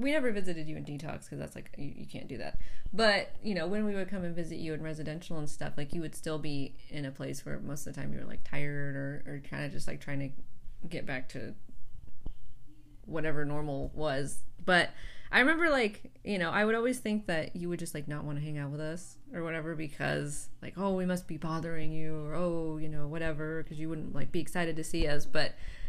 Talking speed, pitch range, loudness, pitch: 245 wpm, 145-175 Hz, -35 LUFS, 155 Hz